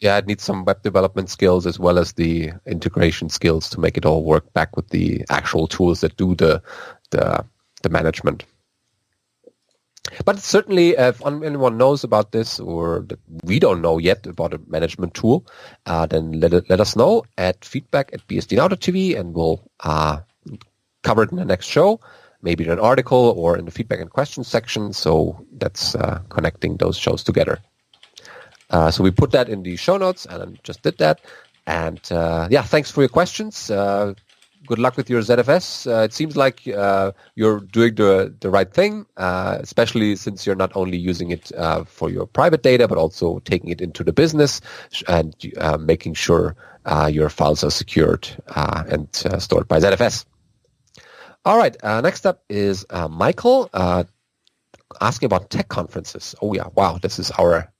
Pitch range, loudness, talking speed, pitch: 85-120 Hz, -19 LUFS, 185 wpm, 95 Hz